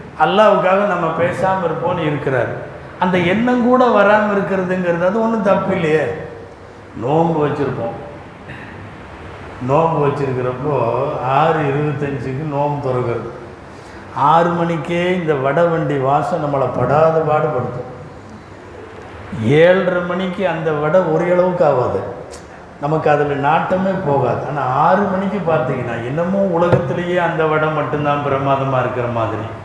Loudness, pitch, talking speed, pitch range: -16 LUFS, 150 Hz, 105 wpm, 125-175 Hz